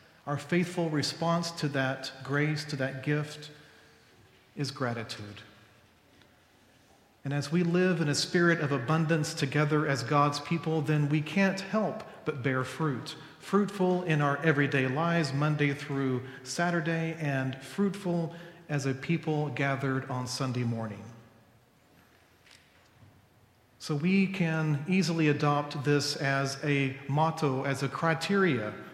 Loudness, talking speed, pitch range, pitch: -29 LUFS, 125 wpm, 130-165 Hz, 145 Hz